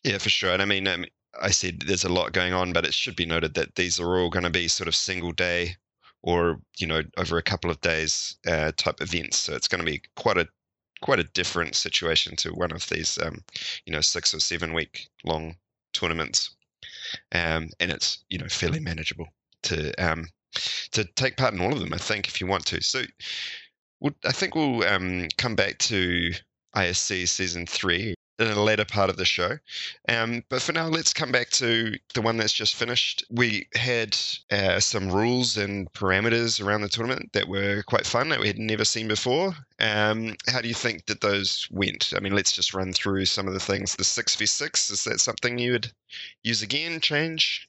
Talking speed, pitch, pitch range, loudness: 215 wpm, 100 Hz, 90-115 Hz, -25 LUFS